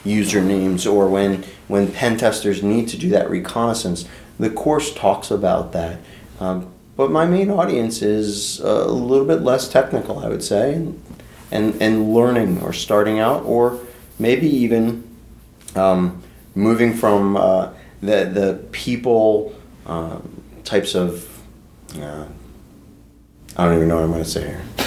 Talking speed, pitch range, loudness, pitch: 145 wpm, 90-115 Hz, -18 LUFS, 105 Hz